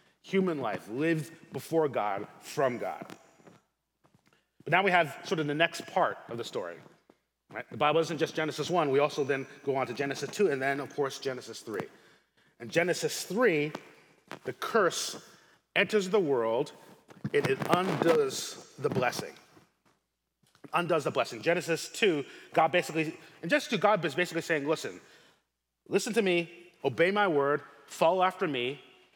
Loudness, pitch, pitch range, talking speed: -30 LUFS, 160 Hz, 140-180 Hz, 160 wpm